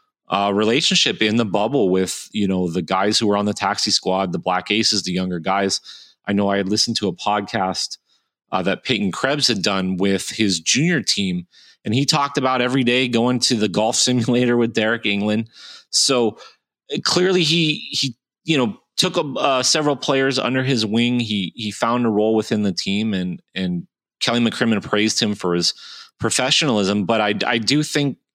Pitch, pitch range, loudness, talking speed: 110 Hz, 100-125 Hz, -19 LUFS, 190 wpm